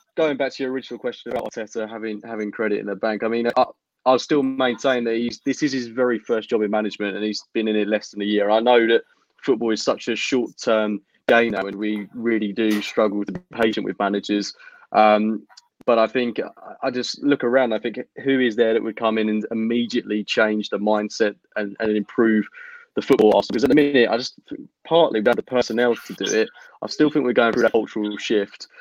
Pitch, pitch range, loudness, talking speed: 115 Hz, 105-125 Hz, -21 LUFS, 225 wpm